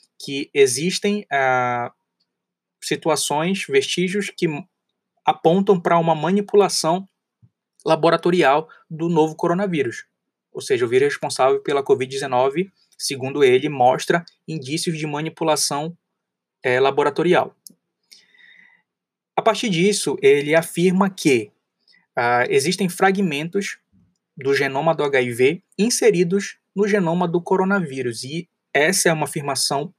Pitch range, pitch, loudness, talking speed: 150-205 Hz, 175 Hz, -20 LUFS, 105 wpm